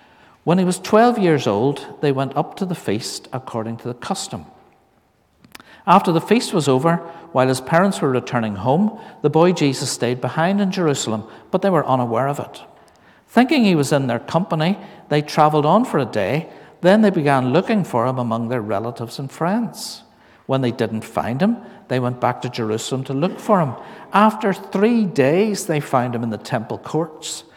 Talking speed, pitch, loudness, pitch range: 190 wpm, 150 Hz, -19 LUFS, 125-190 Hz